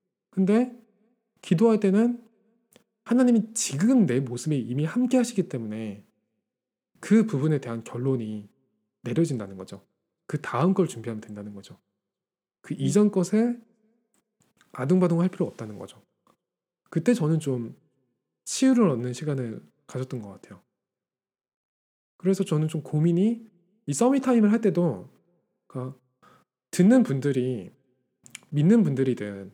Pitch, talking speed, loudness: 165 Hz, 255 characters per minute, -25 LUFS